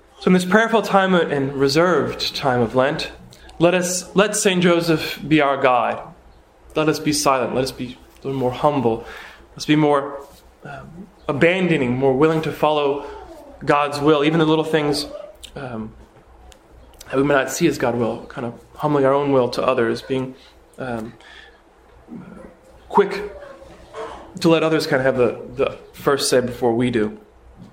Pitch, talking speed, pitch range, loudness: 145 Hz, 165 wpm, 125-165 Hz, -19 LUFS